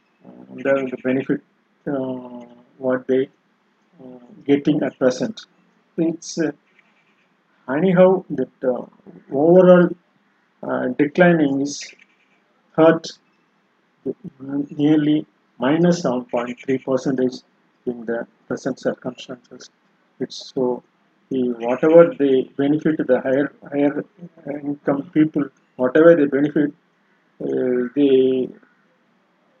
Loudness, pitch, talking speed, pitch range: -19 LUFS, 145 Hz, 90 wpm, 130-175 Hz